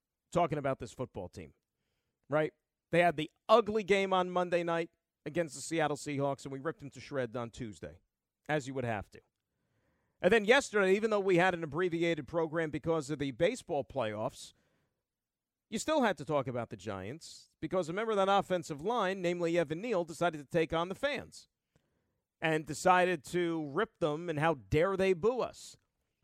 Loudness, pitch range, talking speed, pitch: -33 LUFS, 145-185 Hz, 185 wpm, 165 Hz